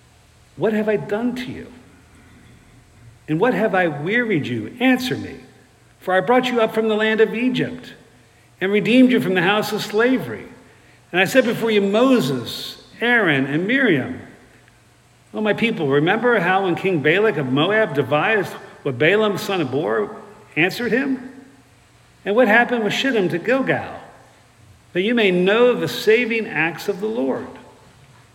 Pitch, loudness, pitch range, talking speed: 205 Hz, -19 LUFS, 145-230 Hz, 165 wpm